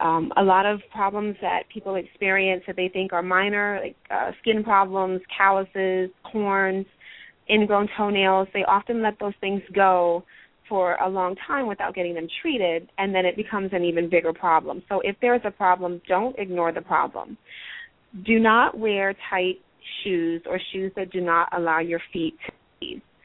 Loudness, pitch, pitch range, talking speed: -23 LUFS, 190 Hz, 180-205 Hz, 175 wpm